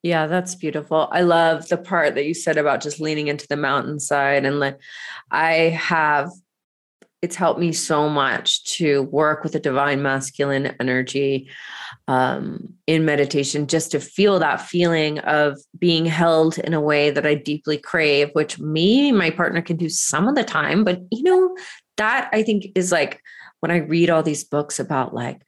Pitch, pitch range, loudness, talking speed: 155 Hz, 145-175 Hz, -20 LUFS, 180 wpm